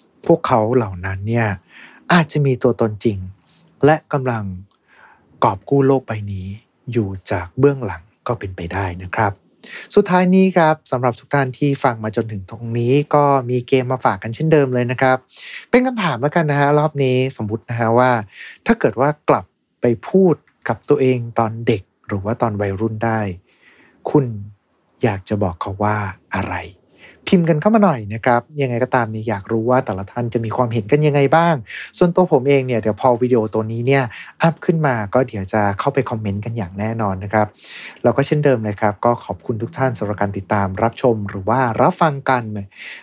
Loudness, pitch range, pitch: -18 LUFS, 105-140 Hz, 120 Hz